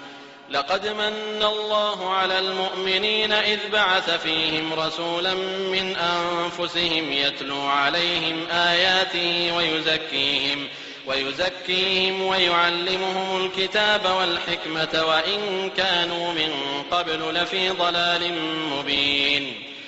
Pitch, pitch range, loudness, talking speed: 175 Hz, 160-190 Hz, -22 LUFS, 80 wpm